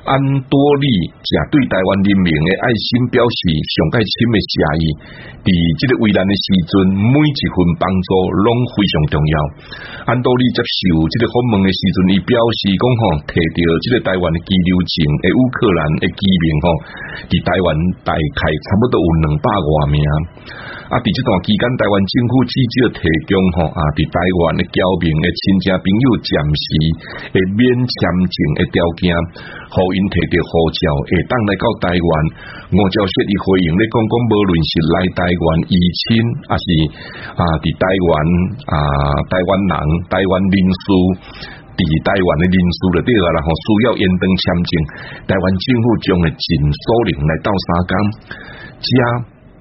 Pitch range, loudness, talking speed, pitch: 85-110 Hz, -15 LUFS, 240 characters per minute, 95 Hz